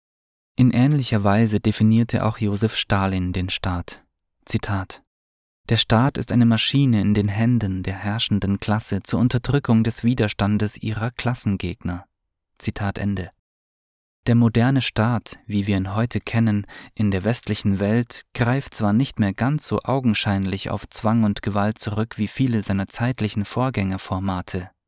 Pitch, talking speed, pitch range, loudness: 105 Hz, 140 wpm, 100-115 Hz, -21 LUFS